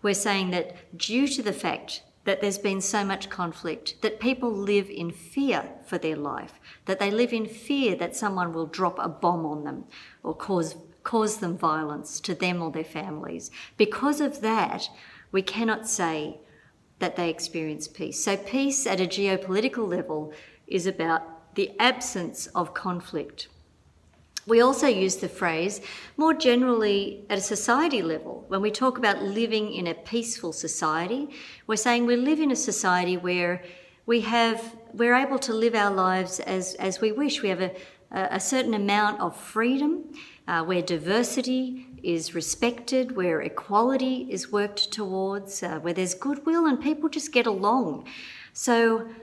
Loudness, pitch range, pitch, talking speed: -26 LUFS, 175-235 Hz, 200 Hz, 165 wpm